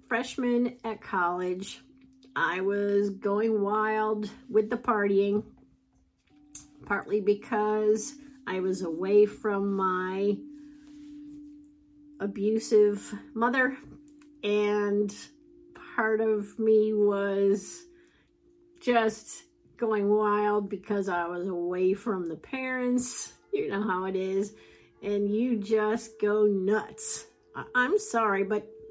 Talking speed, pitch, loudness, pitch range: 100 wpm, 215 Hz, -28 LUFS, 200-255 Hz